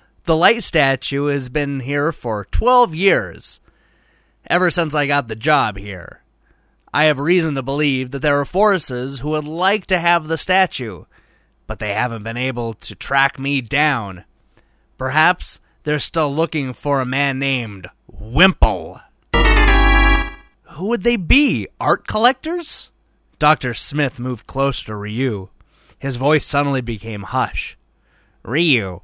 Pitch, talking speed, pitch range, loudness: 140 Hz, 140 wpm, 125-165 Hz, -18 LUFS